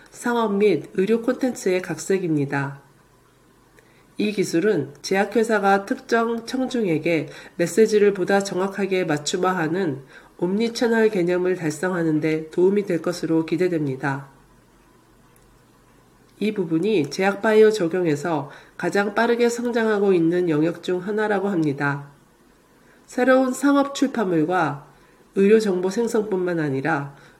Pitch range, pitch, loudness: 160-220 Hz, 185 Hz, -21 LUFS